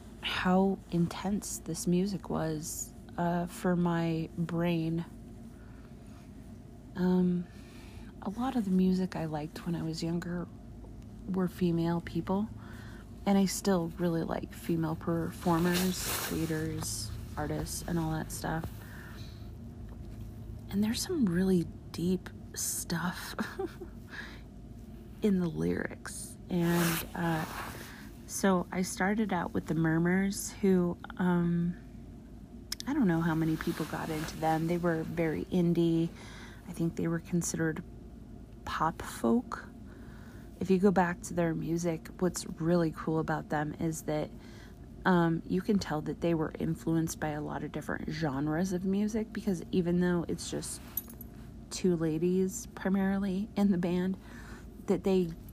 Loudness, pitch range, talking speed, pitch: -32 LUFS, 120-180 Hz, 130 wpm, 165 Hz